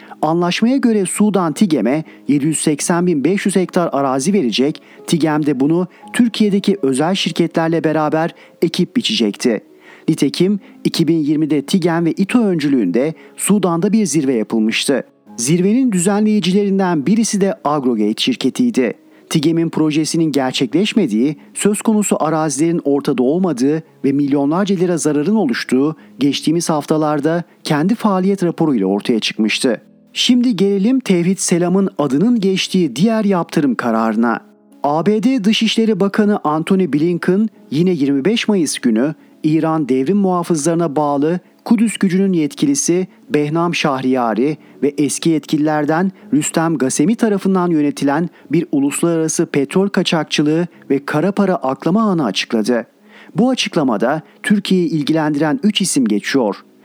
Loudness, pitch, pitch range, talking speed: -16 LUFS, 170 Hz, 150-200 Hz, 110 wpm